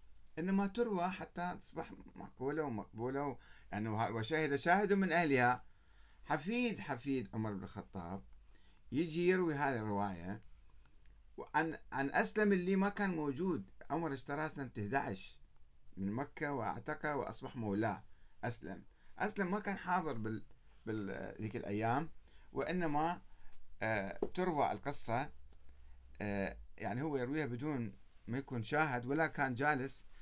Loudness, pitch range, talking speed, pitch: -38 LUFS, 100-155 Hz, 115 wpm, 125 Hz